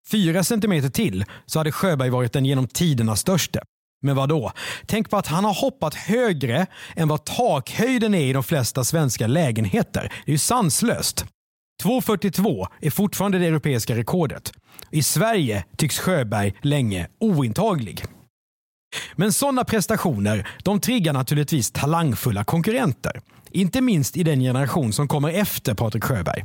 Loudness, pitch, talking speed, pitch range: -22 LUFS, 155 Hz, 145 wpm, 130-190 Hz